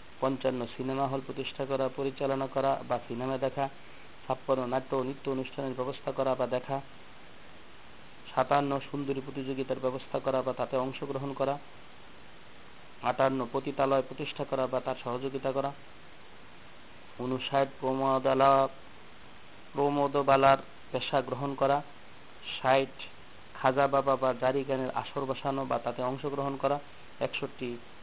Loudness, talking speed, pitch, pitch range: -31 LUFS, 115 wpm, 135 Hz, 130-140 Hz